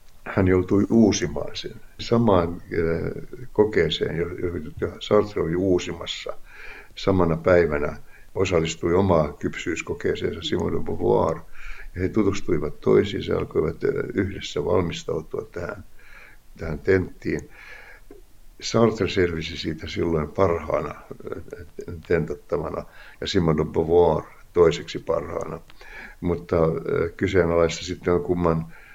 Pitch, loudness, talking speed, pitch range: 90 Hz, -23 LUFS, 95 wpm, 85-100 Hz